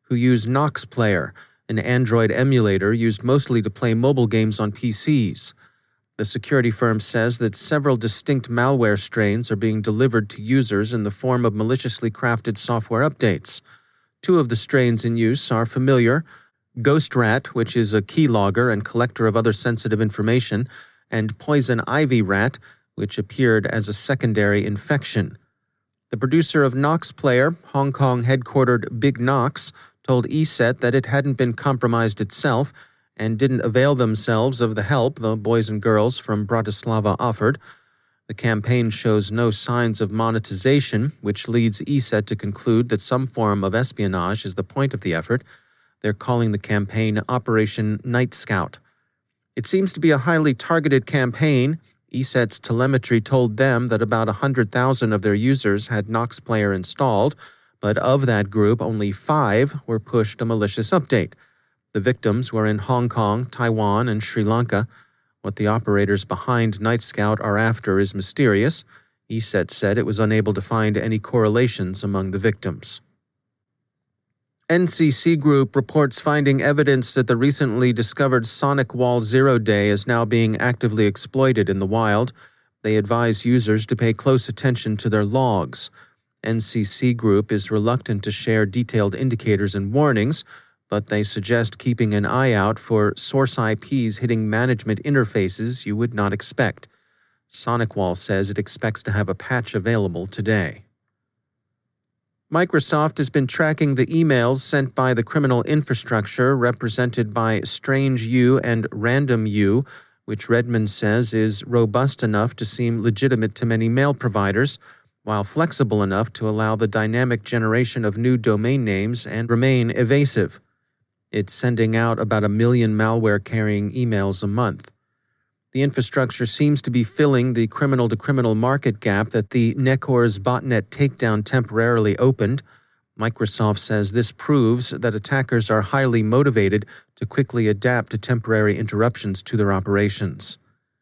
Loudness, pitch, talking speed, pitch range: -20 LUFS, 115 Hz, 150 wpm, 110-130 Hz